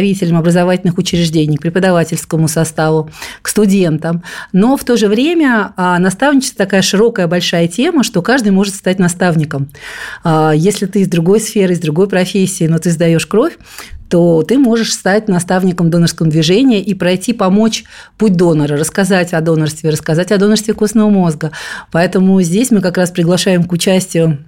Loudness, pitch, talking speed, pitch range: -12 LUFS, 185 Hz, 150 wpm, 170-205 Hz